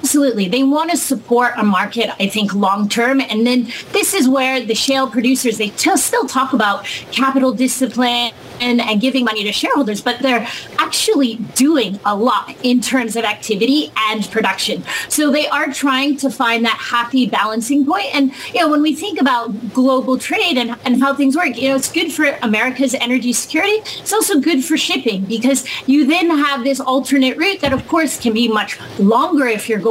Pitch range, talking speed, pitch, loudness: 230-285 Hz, 195 wpm, 260 Hz, -15 LUFS